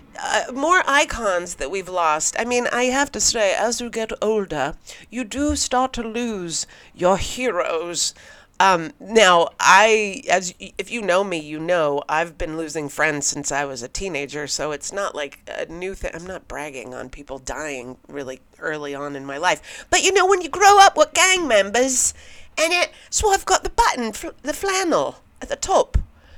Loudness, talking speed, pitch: -19 LUFS, 195 wpm, 195 Hz